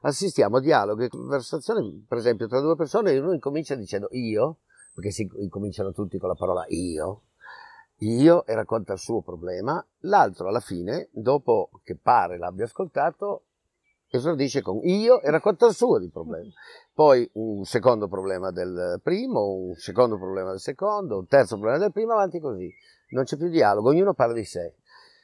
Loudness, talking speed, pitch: -24 LUFS, 170 wpm, 140 Hz